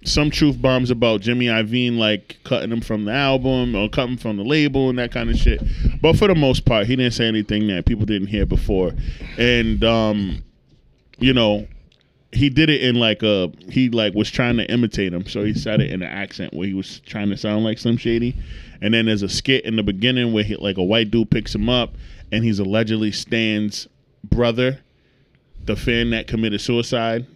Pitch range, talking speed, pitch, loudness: 105-125 Hz, 210 wpm, 115 Hz, -19 LUFS